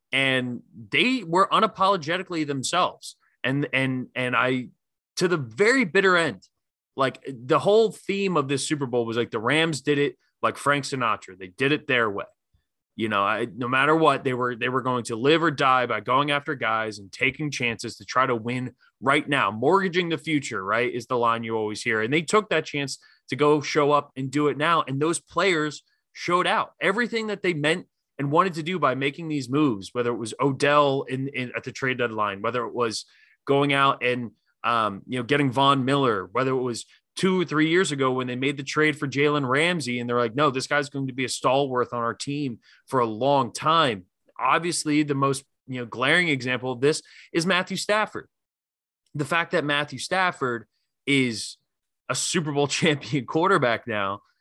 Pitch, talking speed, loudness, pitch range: 140 Hz, 205 wpm, -24 LUFS, 125-155 Hz